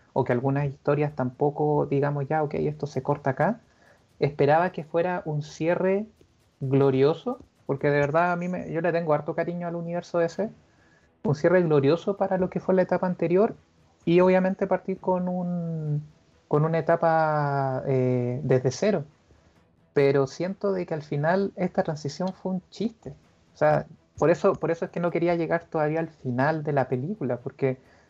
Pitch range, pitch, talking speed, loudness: 140-180 Hz, 160 Hz, 175 wpm, -25 LUFS